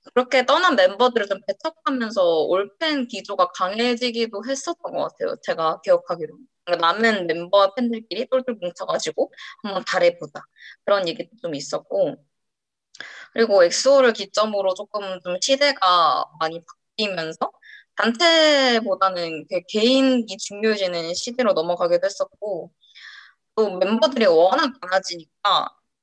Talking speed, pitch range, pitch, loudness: 305 characters per minute, 185-275 Hz, 225 Hz, -21 LUFS